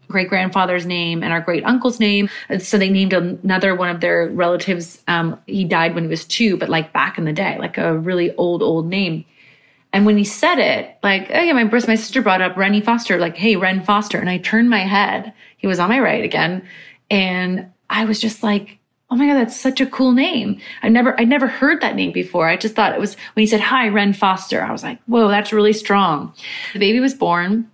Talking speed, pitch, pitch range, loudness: 240 wpm, 200 Hz, 175-225 Hz, -17 LUFS